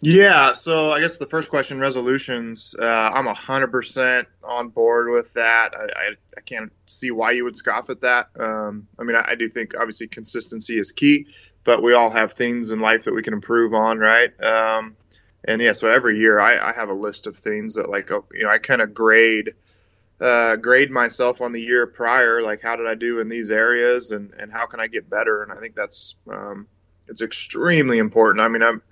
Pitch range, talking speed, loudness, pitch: 110-125 Hz, 220 wpm, -19 LUFS, 115 Hz